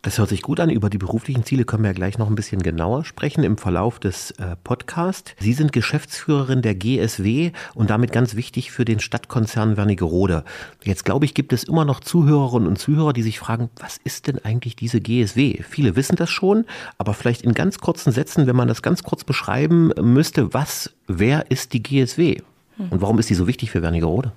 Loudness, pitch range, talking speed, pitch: -20 LUFS, 105-145 Hz, 205 wpm, 120 Hz